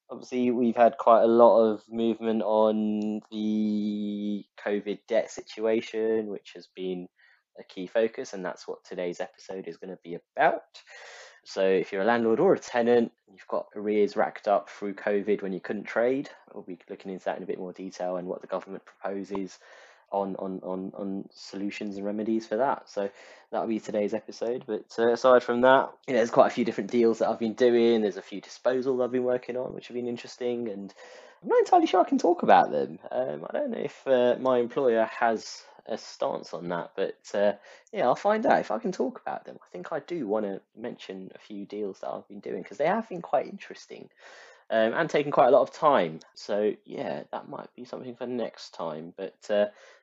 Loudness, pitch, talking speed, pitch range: -27 LUFS, 110 Hz, 215 wpm, 100-120 Hz